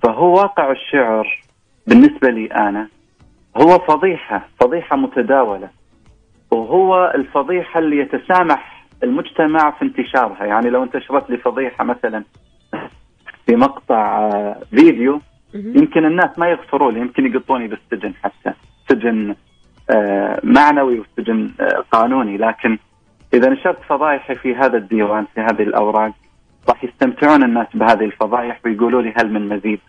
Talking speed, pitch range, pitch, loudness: 115 wpm, 110-155 Hz, 130 Hz, -15 LUFS